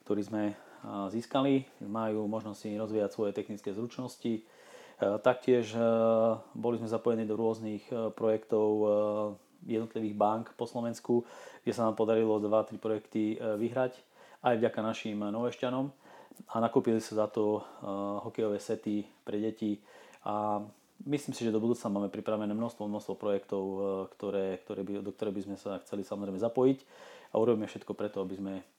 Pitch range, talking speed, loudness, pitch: 105-115 Hz, 145 wpm, -33 LUFS, 110 Hz